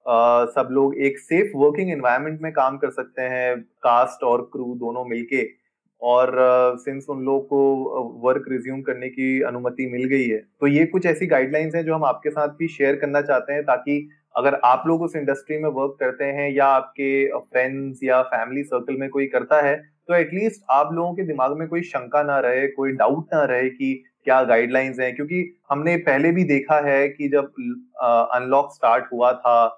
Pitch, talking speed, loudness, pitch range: 140 Hz, 200 wpm, -21 LUFS, 130-150 Hz